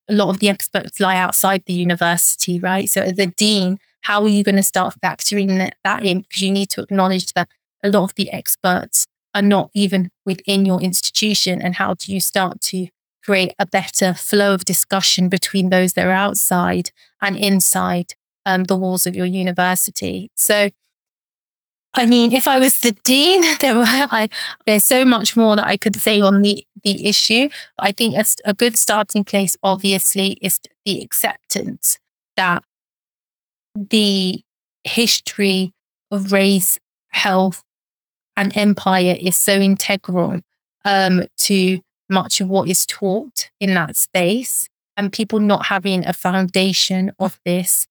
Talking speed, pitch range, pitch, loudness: 160 wpm, 185-205 Hz, 195 Hz, -16 LUFS